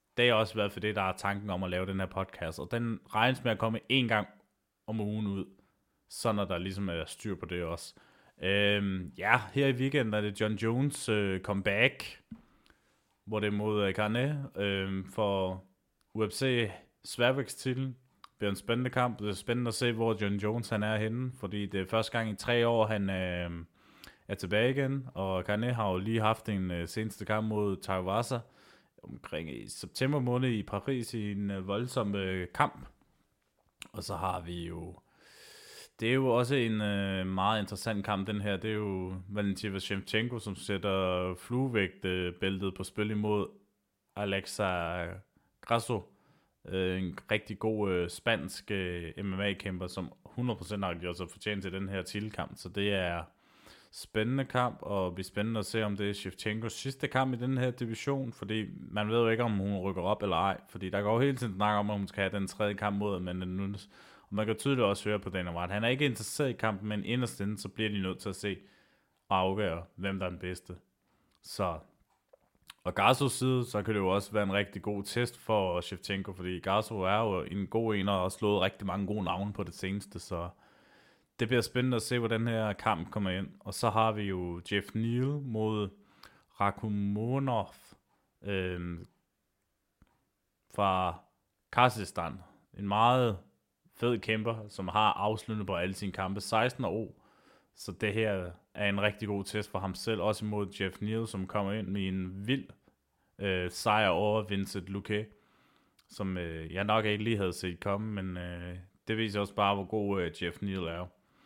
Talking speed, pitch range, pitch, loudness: 190 wpm, 95-110 Hz, 100 Hz, -33 LUFS